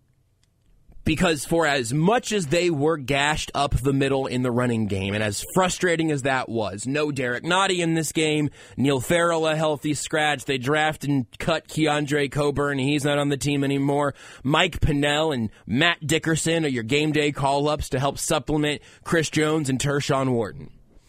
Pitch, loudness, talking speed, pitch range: 145 Hz, -23 LUFS, 180 wpm, 135-155 Hz